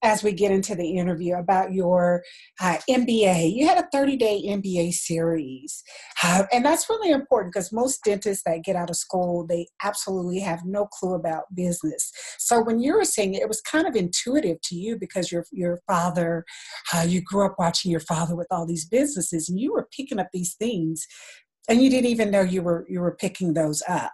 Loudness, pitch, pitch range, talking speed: -24 LUFS, 185 Hz, 175-220 Hz, 205 wpm